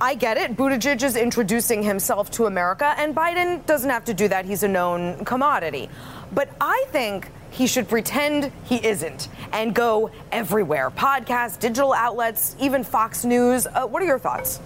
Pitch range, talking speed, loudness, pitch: 210-275 Hz, 170 wpm, -22 LUFS, 235 Hz